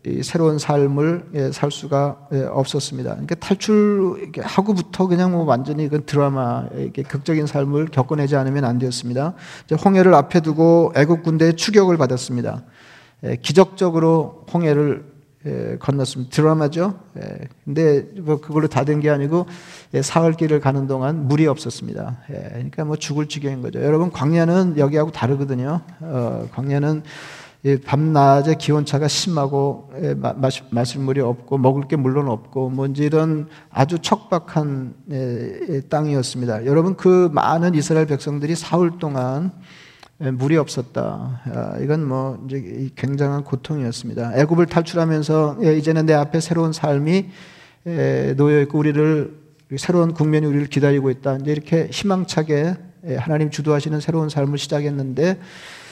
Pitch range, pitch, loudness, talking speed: 135-165 Hz, 150 Hz, -19 LUFS, 335 characters per minute